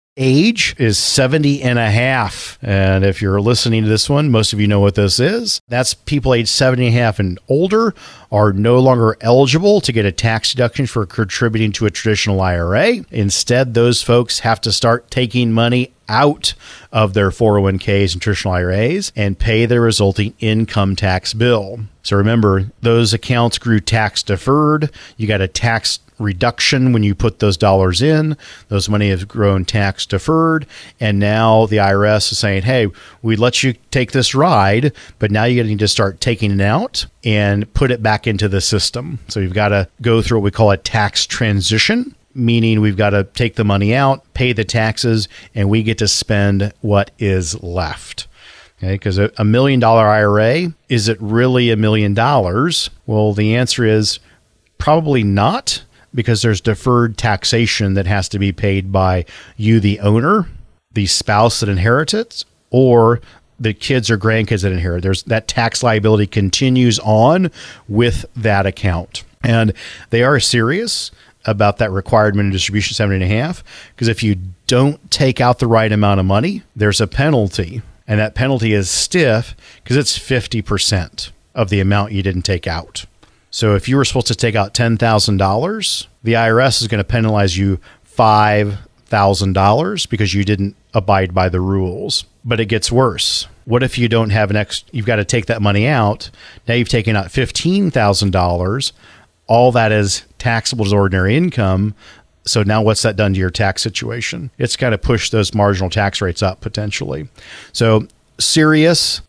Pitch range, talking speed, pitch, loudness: 100-120 Hz, 175 wpm, 110 Hz, -15 LUFS